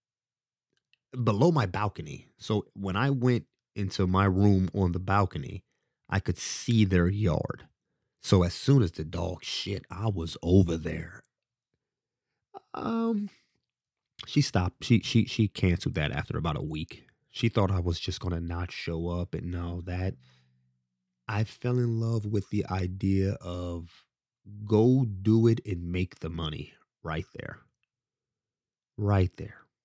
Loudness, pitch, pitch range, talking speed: -28 LUFS, 95 Hz, 85-110 Hz, 145 wpm